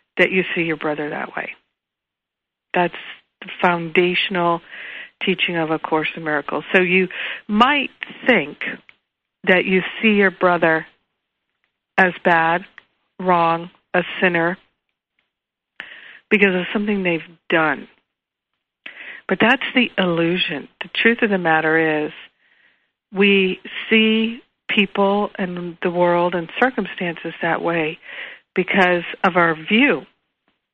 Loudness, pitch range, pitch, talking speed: -18 LUFS, 170-195 Hz, 180 Hz, 115 wpm